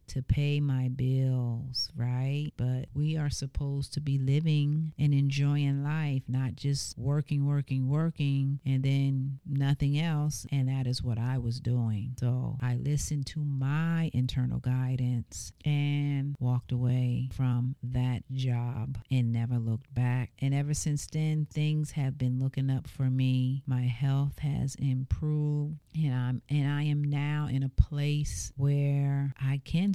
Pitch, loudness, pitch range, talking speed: 135 Hz, -30 LUFS, 125-145 Hz, 150 wpm